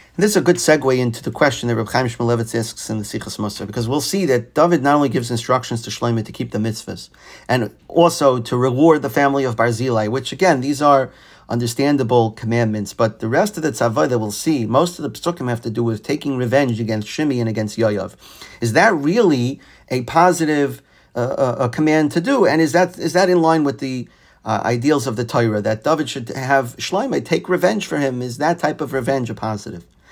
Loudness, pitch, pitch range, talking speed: -18 LUFS, 130 Hz, 115-150 Hz, 220 wpm